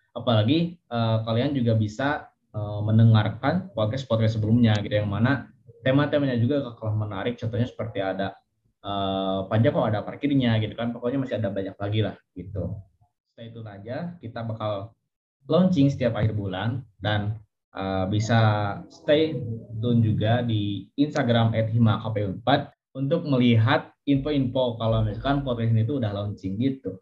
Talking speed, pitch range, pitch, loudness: 140 wpm, 105-130 Hz, 115 Hz, -25 LUFS